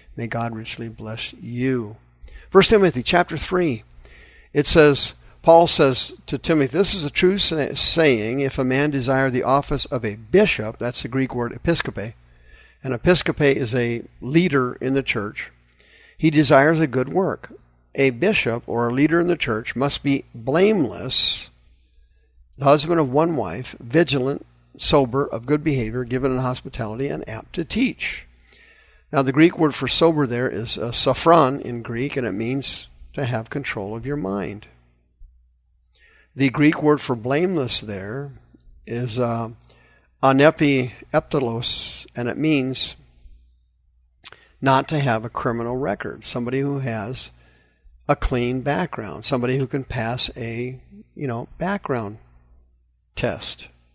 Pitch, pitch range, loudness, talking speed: 130 Hz, 110-145 Hz, -20 LUFS, 145 wpm